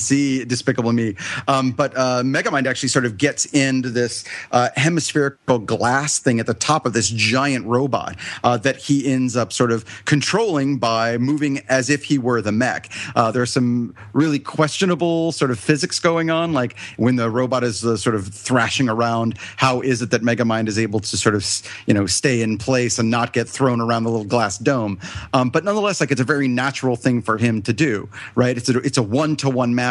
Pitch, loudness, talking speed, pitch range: 125 Hz, -19 LUFS, 215 wpm, 115-140 Hz